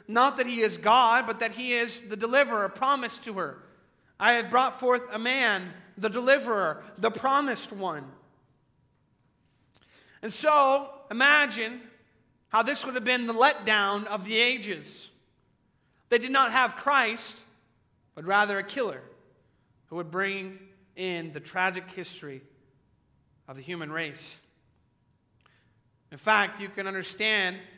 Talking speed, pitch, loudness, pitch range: 135 wpm, 210 Hz, -26 LUFS, 165-240 Hz